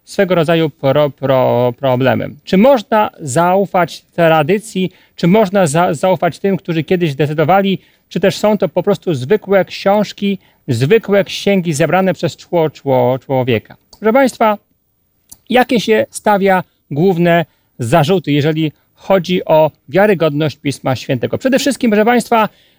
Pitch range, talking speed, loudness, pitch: 155-200 Hz, 125 wpm, -14 LUFS, 180 Hz